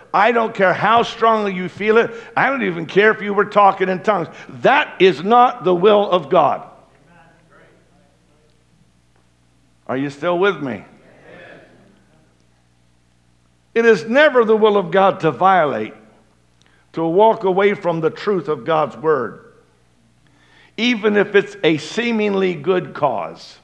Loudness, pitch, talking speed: -16 LUFS, 185 Hz, 140 wpm